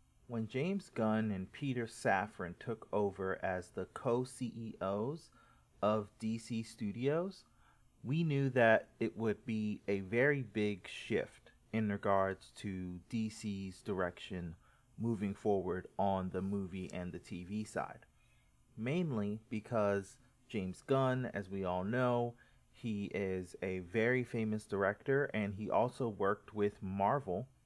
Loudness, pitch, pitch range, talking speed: -37 LUFS, 110 Hz, 100-120 Hz, 130 wpm